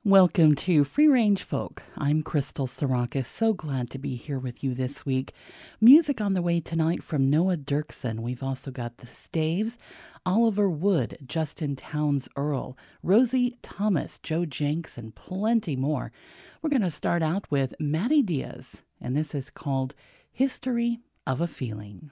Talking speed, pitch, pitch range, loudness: 155 wpm, 150 Hz, 135-195 Hz, -27 LUFS